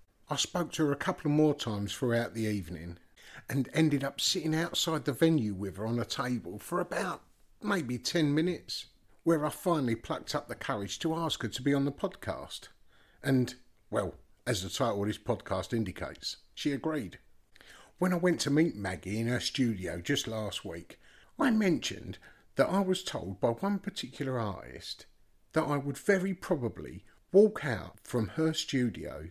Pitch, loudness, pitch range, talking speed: 135 Hz, -32 LUFS, 105-160 Hz, 180 wpm